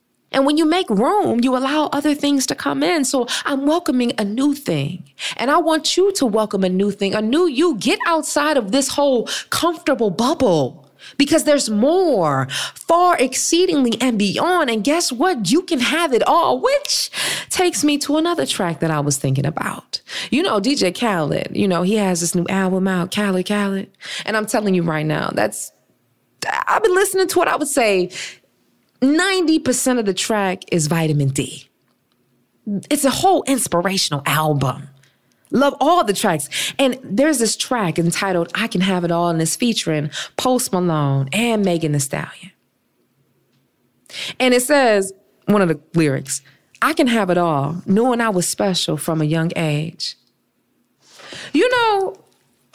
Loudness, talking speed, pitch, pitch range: -18 LUFS, 170 wpm, 220 Hz, 170-290 Hz